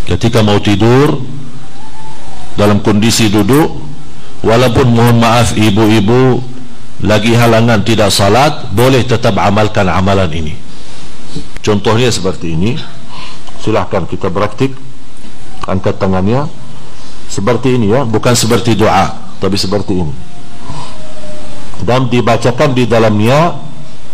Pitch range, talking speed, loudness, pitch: 105-125 Hz, 100 wpm, -11 LUFS, 115 Hz